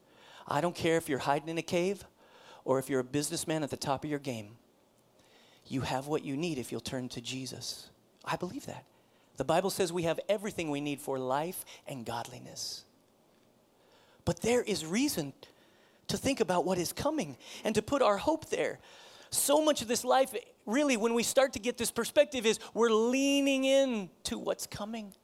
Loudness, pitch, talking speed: -32 LUFS, 190 Hz, 195 wpm